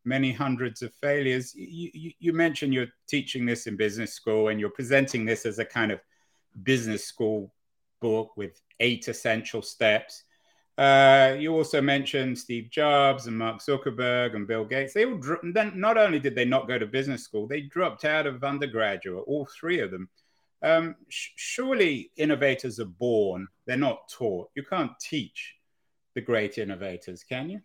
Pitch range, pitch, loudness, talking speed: 115-150 Hz, 130 Hz, -26 LUFS, 170 wpm